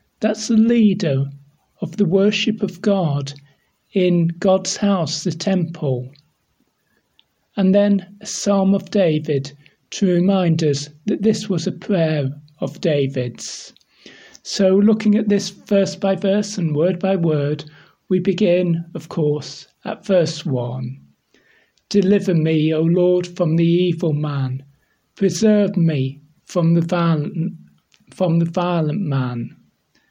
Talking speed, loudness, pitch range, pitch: 130 wpm, -19 LUFS, 150-195 Hz, 175 Hz